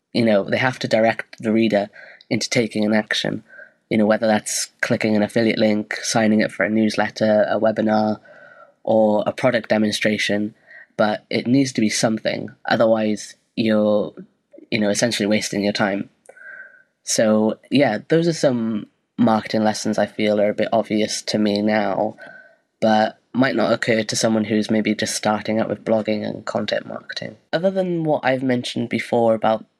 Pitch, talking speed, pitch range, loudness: 110 Hz, 170 wpm, 105-115 Hz, -20 LUFS